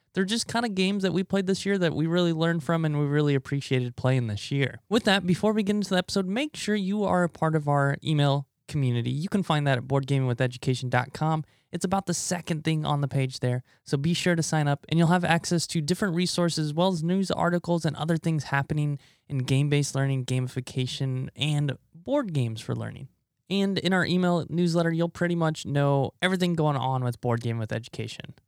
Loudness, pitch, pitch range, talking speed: -26 LUFS, 155 Hz, 135-180 Hz, 220 wpm